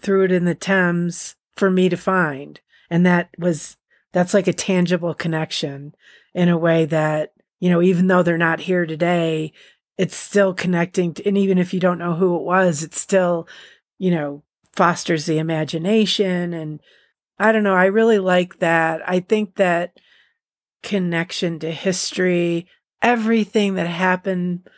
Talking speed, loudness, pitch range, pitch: 160 wpm, -19 LUFS, 165-190 Hz, 180 Hz